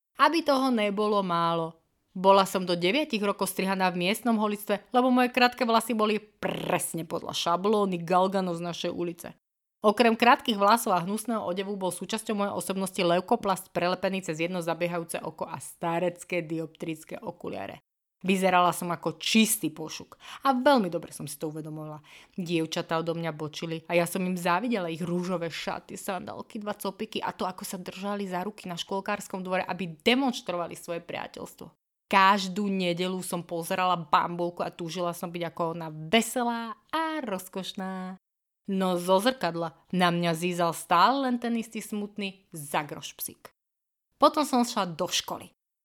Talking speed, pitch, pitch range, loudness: 155 wpm, 185 Hz, 175-210 Hz, -28 LUFS